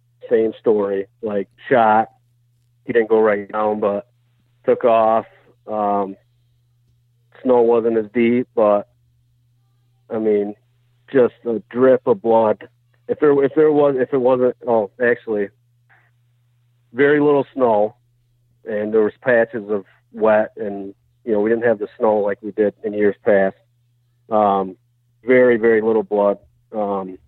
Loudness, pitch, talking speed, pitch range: -18 LUFS, 120 Hz, 140 wpm, 105-120 Hz